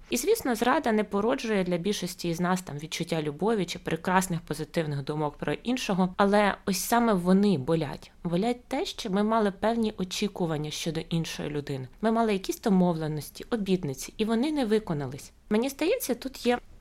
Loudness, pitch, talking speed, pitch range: -28 LUFS, 190 Hz, 165 wpm, 165-225 Hz